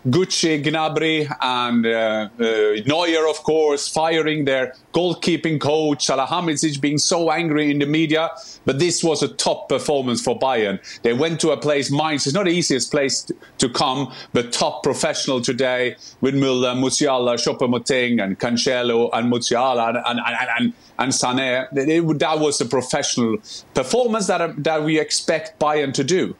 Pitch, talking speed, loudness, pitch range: 145 Hz, 165 wpm, -19 LUFS, 125-160 Hz